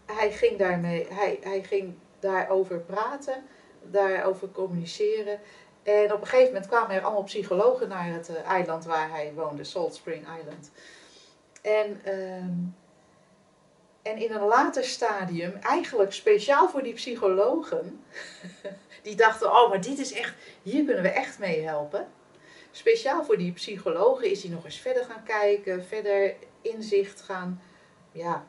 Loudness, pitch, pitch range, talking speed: -27 LUFS, 200 Hz, 180-220 Hz, 145 wpm